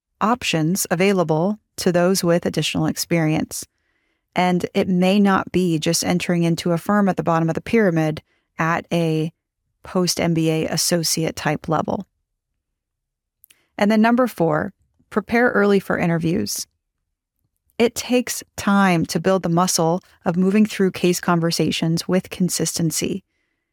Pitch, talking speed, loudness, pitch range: 180 Hz, 130 wpm, -20 LUFS, 165-195 Hz